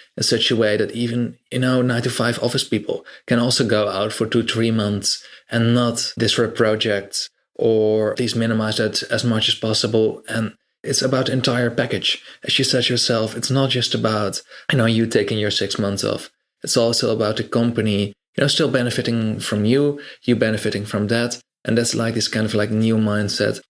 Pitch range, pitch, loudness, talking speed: 110-125 Hz, 115 Hz, -19 LUFS, 200 wpm